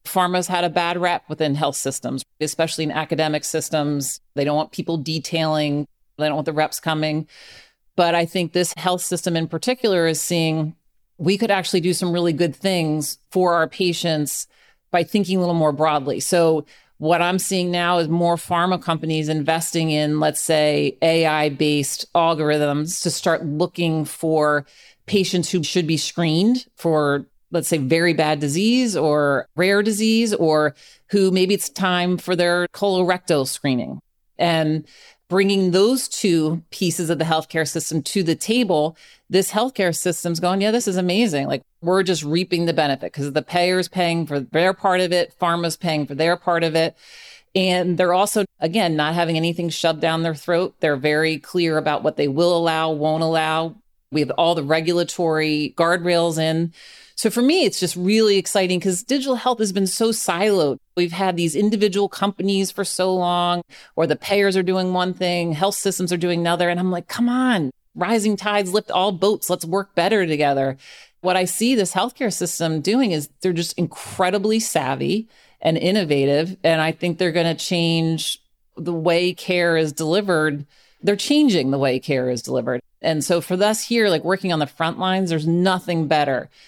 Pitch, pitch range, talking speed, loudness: 170 Hz, 155-185 Hz, 180 wpm, -20 LUFS